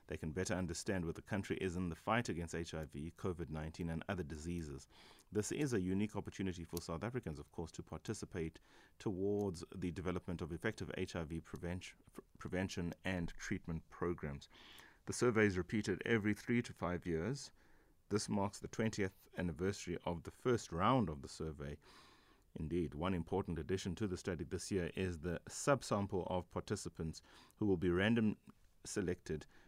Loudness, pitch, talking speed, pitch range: -41 LUFS, 90 Hz, 165 wpm, 85-100 Hz